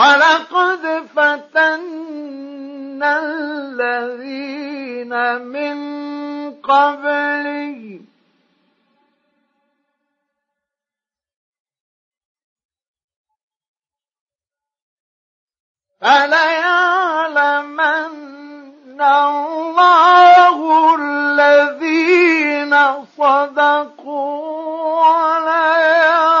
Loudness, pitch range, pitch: -14 LUFS, 285-320 Hz, 290 Hz